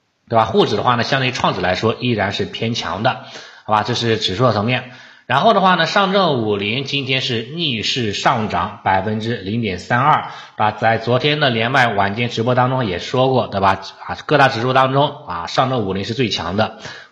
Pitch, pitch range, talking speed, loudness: 120 Hz, 110-130 Hz, 300 characters per minute, -17 LUFS